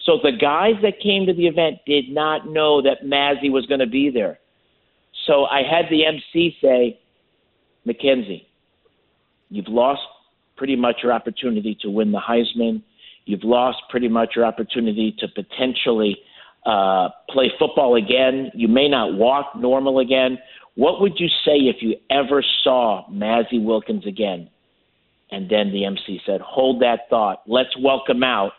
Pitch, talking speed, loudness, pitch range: 130 Hz, 155 wpm, -19 LUFS, 115-140 Hz